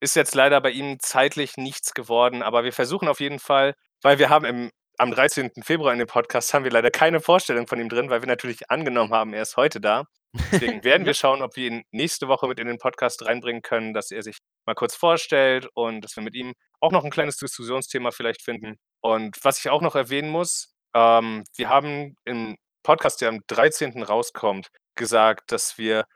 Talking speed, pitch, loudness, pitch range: 215 wpm, 125 Hz, -22 LUFS, 115-140 Hz